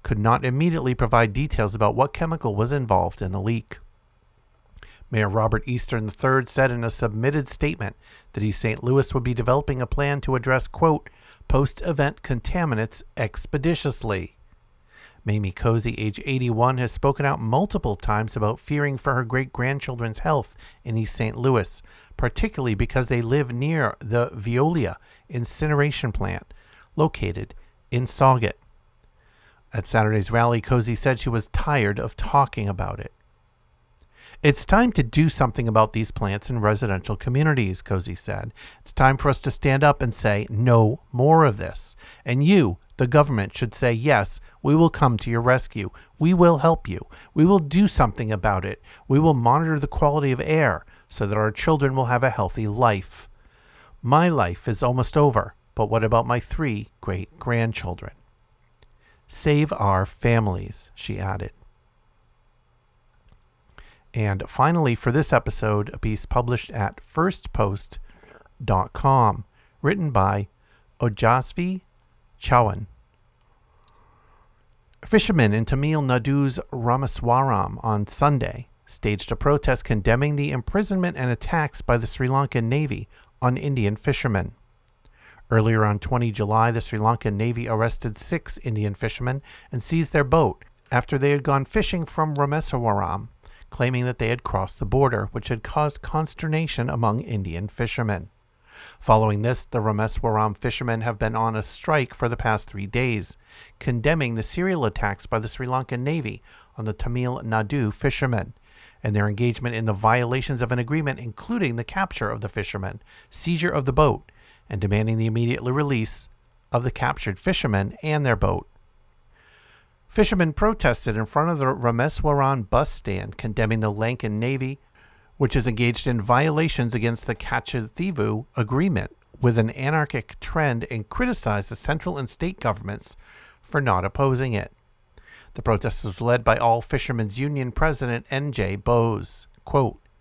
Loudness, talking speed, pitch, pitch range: -23 LUFS, 150 wpm, 120 Hz, 110-140 Hz